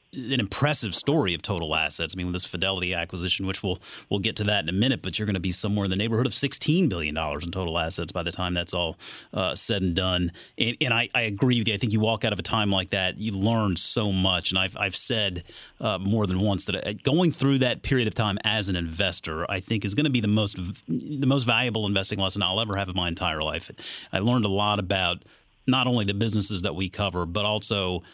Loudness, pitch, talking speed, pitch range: -25 LUFS, 100 Hz, 255 wpm, 90-115 Hz